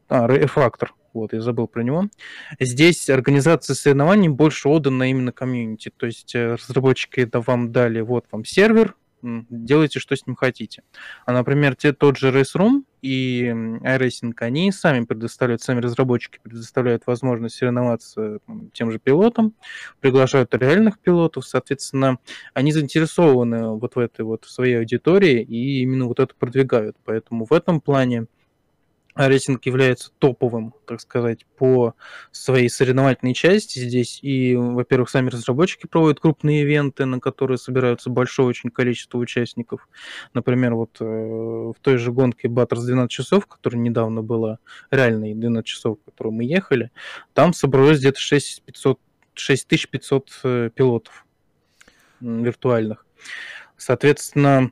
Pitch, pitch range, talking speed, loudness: 130 Hz, 120-140 Hz, 135 wpm, -19 LUFS